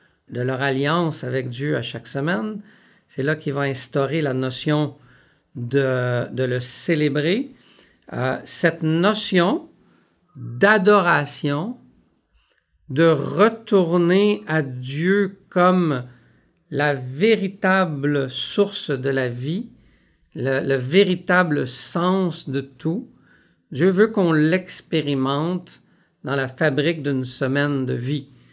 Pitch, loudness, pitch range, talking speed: 150 Hz, -21 LUFS, 135-180 Hz, 105 wpm